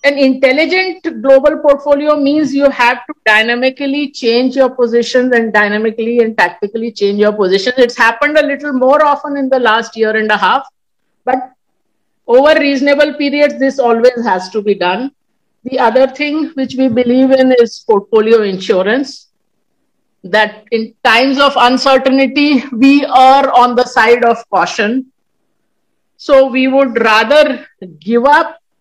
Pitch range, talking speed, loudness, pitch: 230-280 Hz, 145 wpm, -11 LUFS, 255 Hz